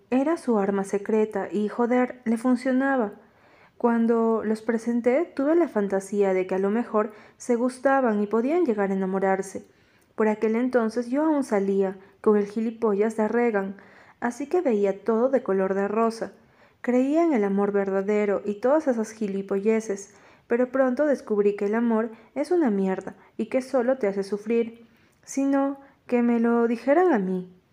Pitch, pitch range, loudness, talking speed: 225 Hz, 200-250 Hz, -24 LUFS, 165 wpm